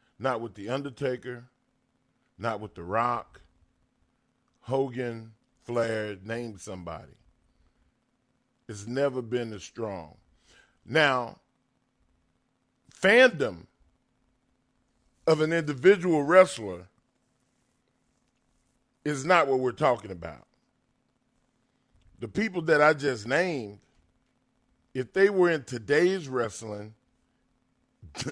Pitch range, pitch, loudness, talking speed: 110-135 Hz, 125 Hz, -26 LUFS, 85 wpm